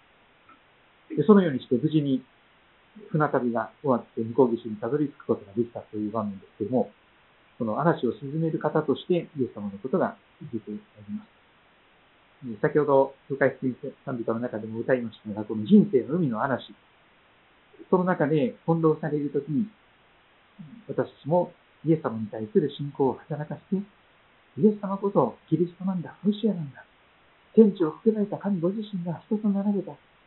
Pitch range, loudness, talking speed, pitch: 120-185 Hz, -26 LUFS, 330 characters per minute, 150 Hz